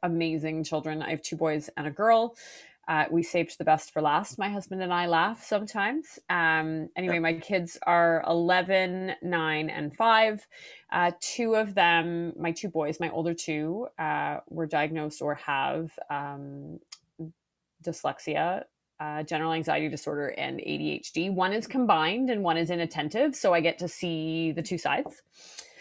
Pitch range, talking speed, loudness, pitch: 155-190 Hz, 160 wpm, -28 LUFS, 170 Hz